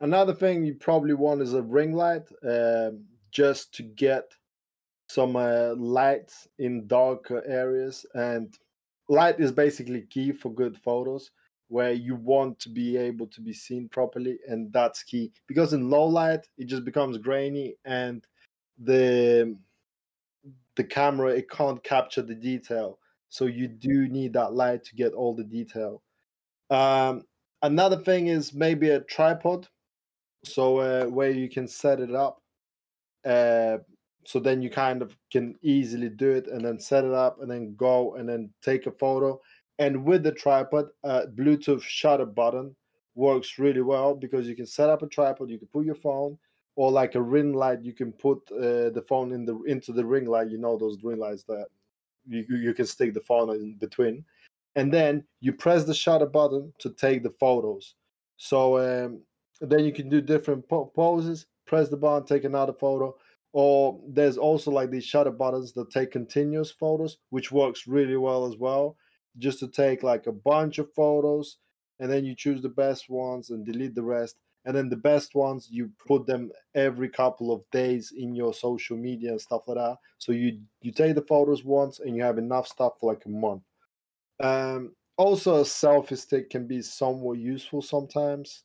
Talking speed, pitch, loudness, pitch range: 180 wpm, 130 Hz, -26 LUFS, 120-145 Hz